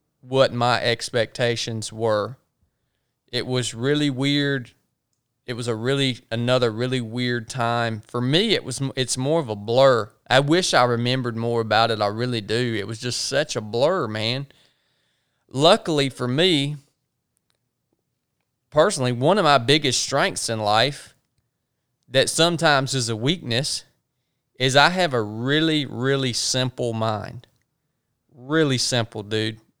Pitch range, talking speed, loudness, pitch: 115-140 Hz, 140 wpm, -21 LUFS, 125 Hz